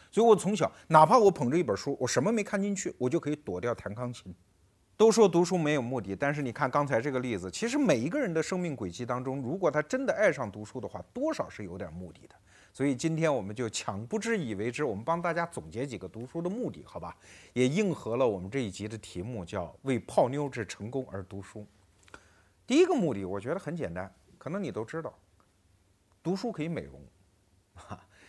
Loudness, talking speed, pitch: -30 LUFS, 325 characters per minute, 125 Hz